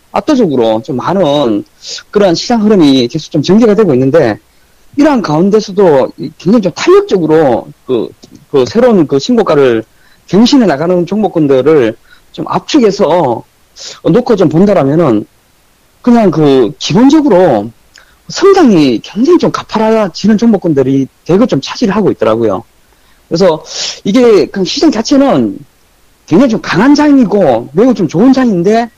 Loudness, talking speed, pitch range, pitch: -9 LUFS, 295 characters per minute, 165-250 Hz, 210 Hz